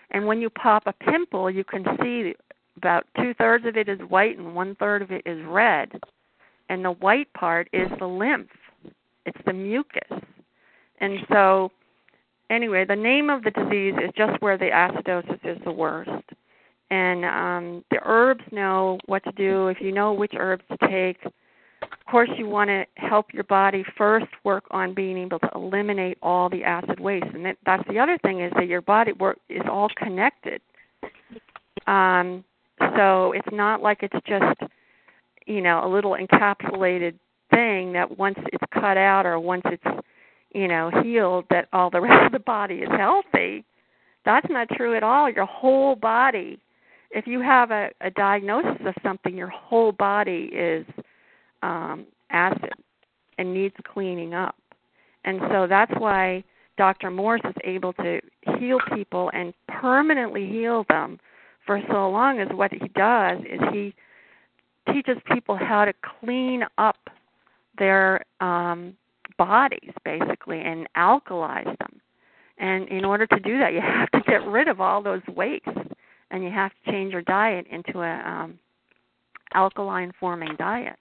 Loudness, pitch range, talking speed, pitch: -22 LUFS, 185-220 Hz, 165 wpm, 195 Hz